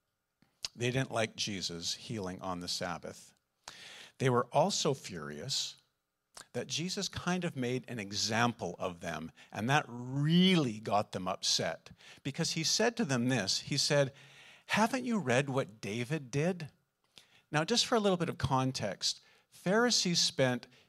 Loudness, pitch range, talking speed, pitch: -32 LUFS, 110-165 Hz, 145 wpm, 130 Hz